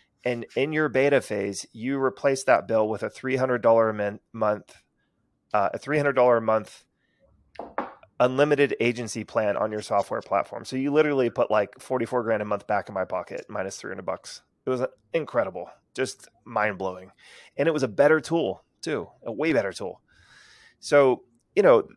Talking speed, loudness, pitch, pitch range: 185 wpm, -25 LUFS, 120 Hz, 105-130 Hz